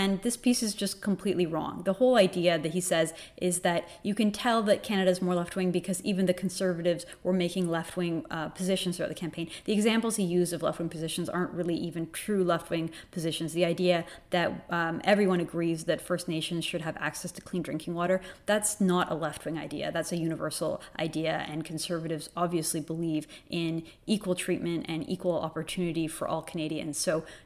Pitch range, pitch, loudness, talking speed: 165-185 Hz, 175 Hz, -30 LUFS, 190 wpm